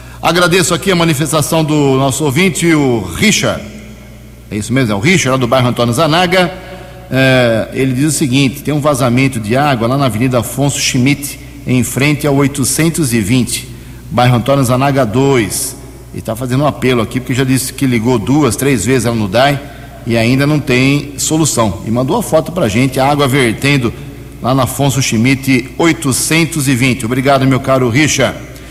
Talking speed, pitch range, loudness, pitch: 175 wpm, 125-145 Hz, -12 LUFS, 135 Hz